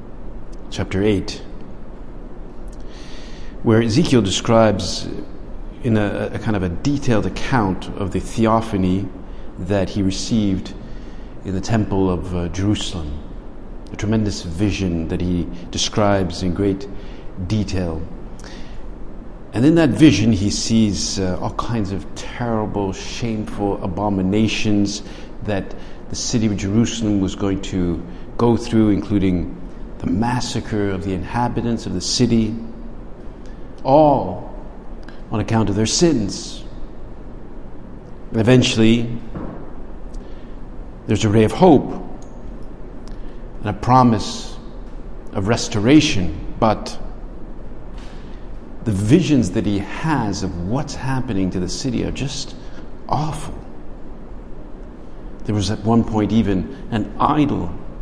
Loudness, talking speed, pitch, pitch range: -19 LUFS, 110 wpm, 100 Hz, 90-110 Hz